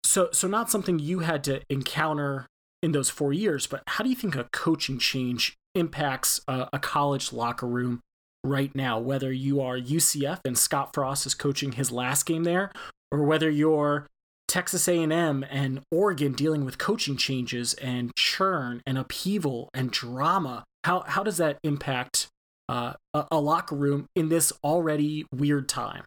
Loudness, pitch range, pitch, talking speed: -26 LUFS, 130-160 Hz, 145 Hz, 170 wpm